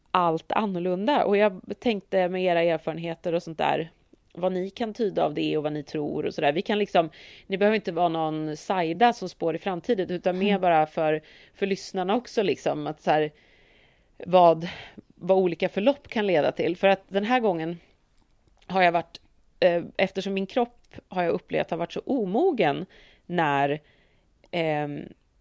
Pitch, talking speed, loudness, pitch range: 180 Hz, 175 wpm, -25 LUFS, 160-195 Hz